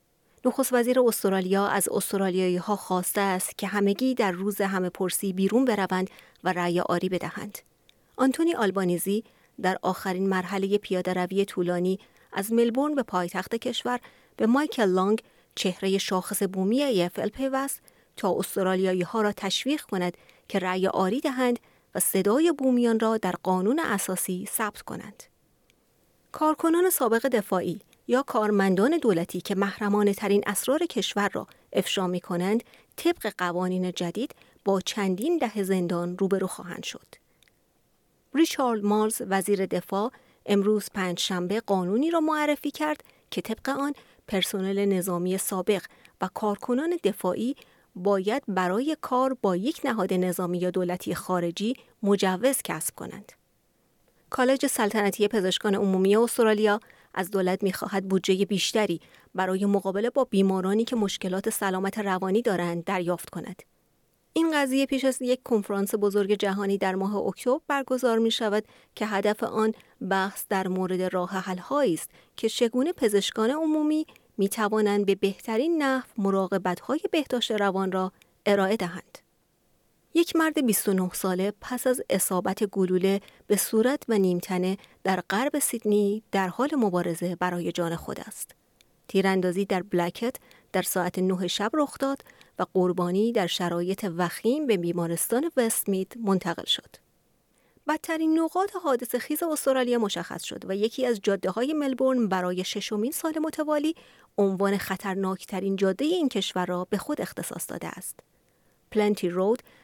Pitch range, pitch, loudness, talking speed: 190-245 Hz, 200 Hz, -26 LUFS, 135 wpm